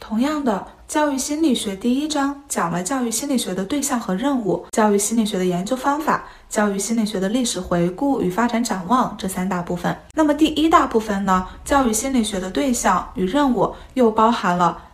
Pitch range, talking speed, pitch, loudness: 190-275 Hz, 310 characters per minute, 230 Hz, -20 LUFS